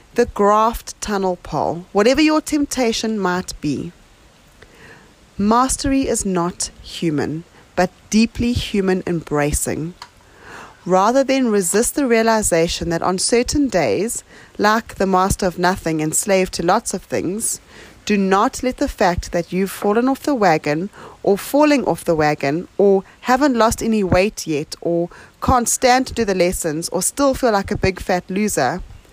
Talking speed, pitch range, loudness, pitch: 150 wpm, 175-235 Hz, -18 LUFS, 195 Hz